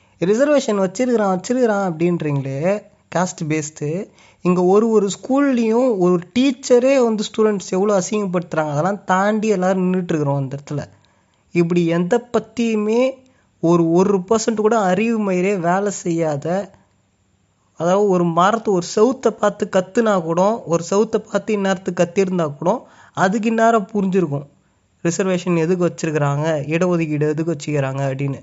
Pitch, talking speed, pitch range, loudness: 185 Hz, 120 wpm, 165-215 Hz, -18 LUFS